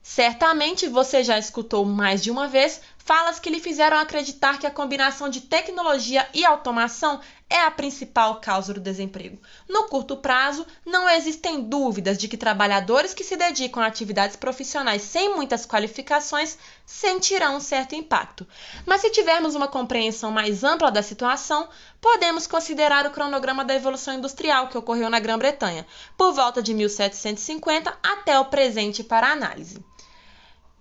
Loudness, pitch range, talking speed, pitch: -22 LUFS, 230-315 Hz, 150 wpm, 275 Hz